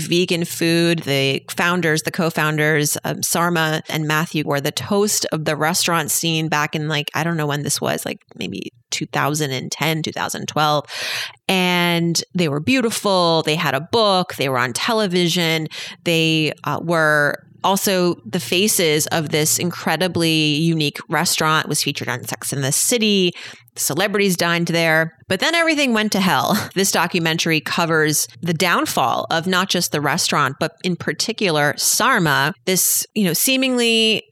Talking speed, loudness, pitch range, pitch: 155 wpm, -18 LUFS, 150-180 Hz, 165 Hz